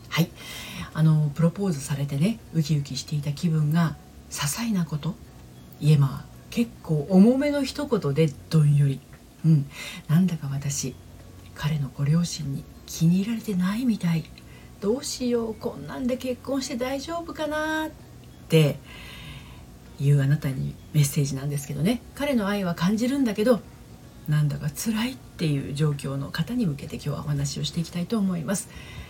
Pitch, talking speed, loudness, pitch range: 160 Hz, 320 characters per minute, -25 LUFS, 140-215 Hz